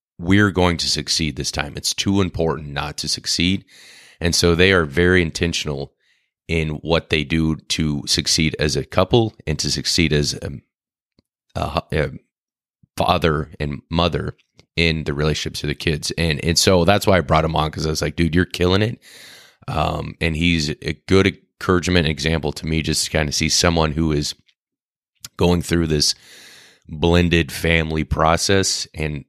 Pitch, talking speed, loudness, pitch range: 80 Hz, 170 wpm, -19 LUFS, 75-90 Hz